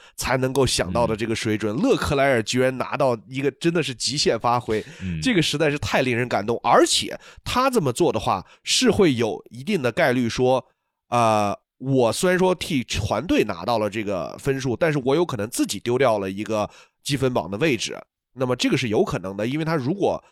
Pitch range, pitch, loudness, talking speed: 110-140 Hz, 125 Hz, -22 LUFS, 300 characters per minute